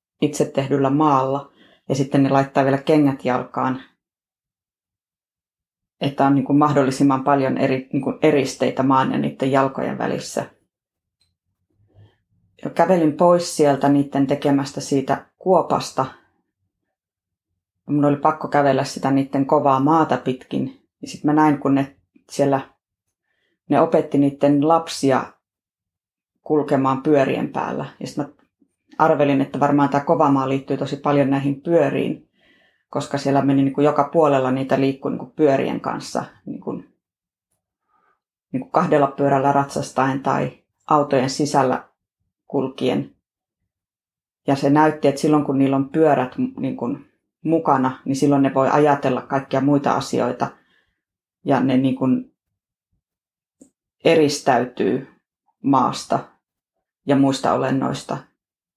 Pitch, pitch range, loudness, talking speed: 140 Hz, 130-145 Hz, -19 LUFS, 120 wpm